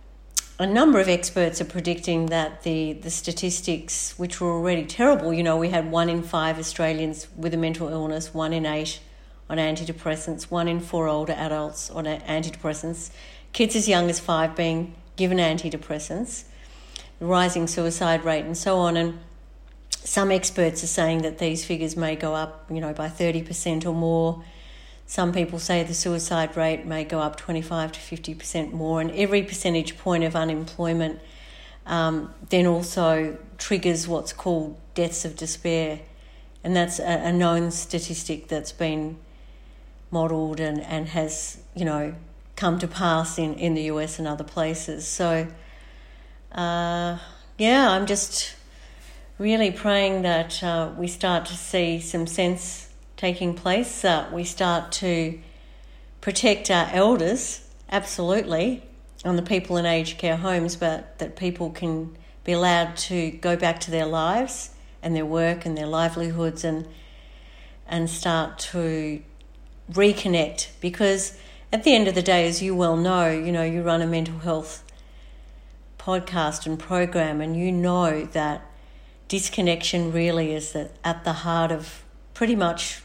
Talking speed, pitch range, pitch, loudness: 155 wpm, 160-175 Hz, 165 Hz, -24 LUFS